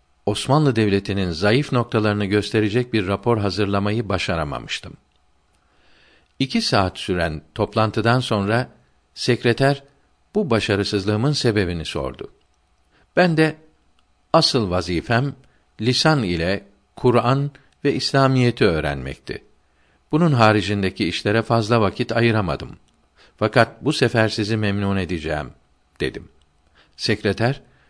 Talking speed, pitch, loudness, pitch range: 90 wpm, 105 Hz, -20 LUFS, 90-125 Hz